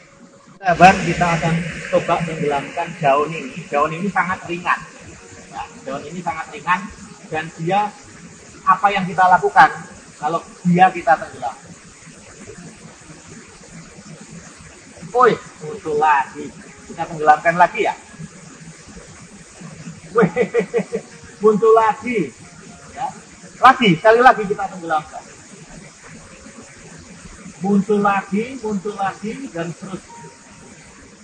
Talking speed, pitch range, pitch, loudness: 90 wpm, 170-215 Hz, 185 Hz, -17 LUFS